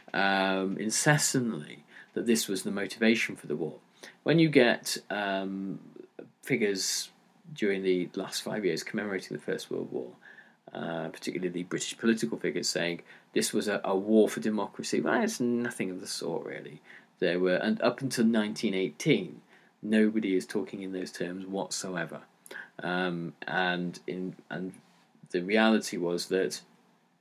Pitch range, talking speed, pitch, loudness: 90-115 Hz, 150 wpm, 100 Hz, -30 LUFS